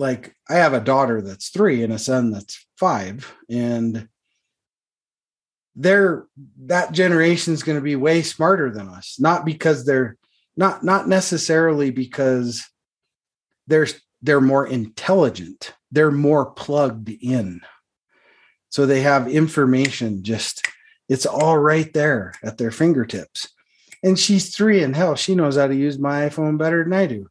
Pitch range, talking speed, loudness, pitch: 125-165 Hz, 145 wpm, -19 LUFS, 145 Hz